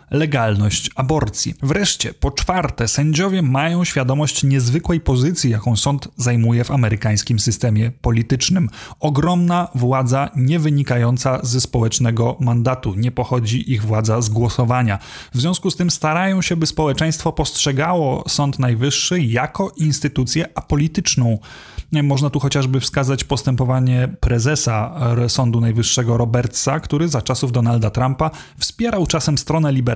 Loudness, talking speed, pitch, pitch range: -17 LUFS, 125 wpm, 135 Hz, 120-155 Hz